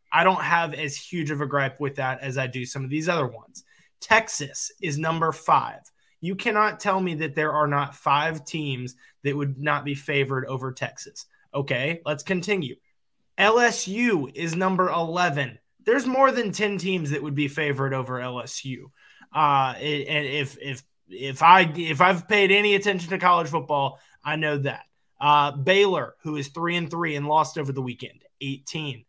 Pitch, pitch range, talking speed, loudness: 150 Hz, 140-180 Hz, 180 wpm, -23 LUFS